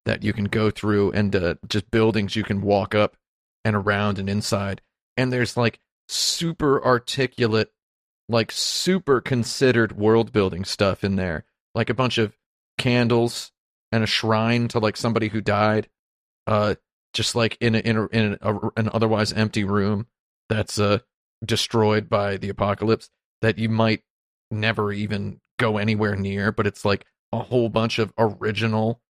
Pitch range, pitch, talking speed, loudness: 105-115 Hz, 110 Hz, 165 wpm, -23 LUFS